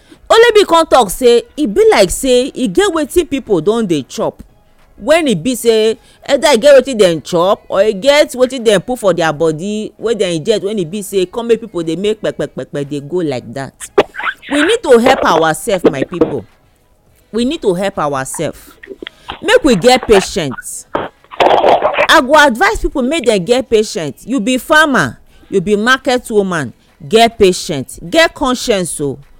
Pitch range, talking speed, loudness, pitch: 190-290 Hz, 180 wpm, -12 LUFS, 230 Hz